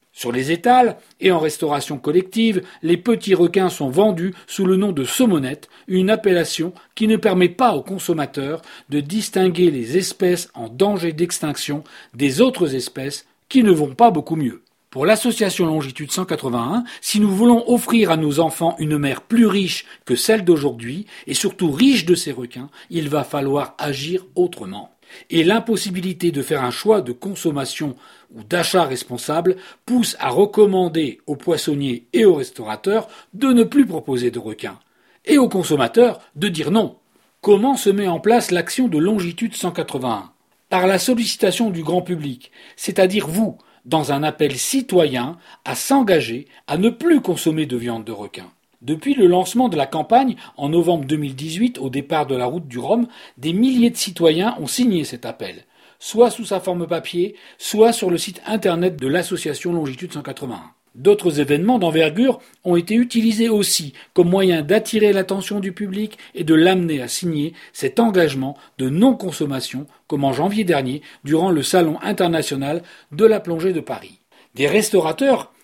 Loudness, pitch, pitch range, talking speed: -18 LUFS, 180 Hz, 150-215 Hz, 165 wpm